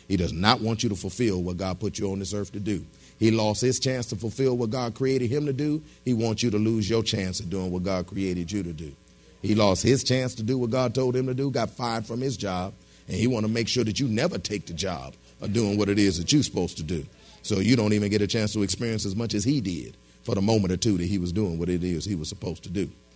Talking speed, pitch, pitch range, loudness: 295 wpm, 105 Hz, 95-120 Hz, -26 LUFS